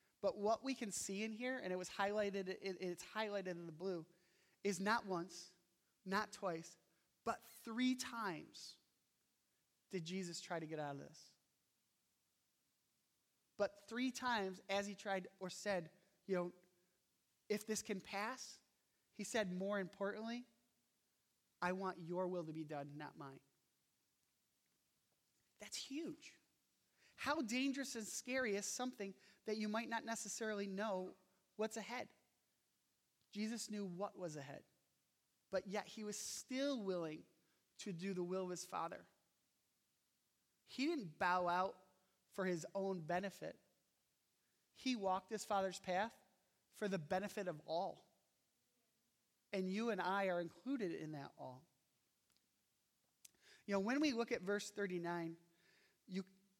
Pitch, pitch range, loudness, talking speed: 195 Hz, 180-220 Hz, -44 LUFS, 135 wpm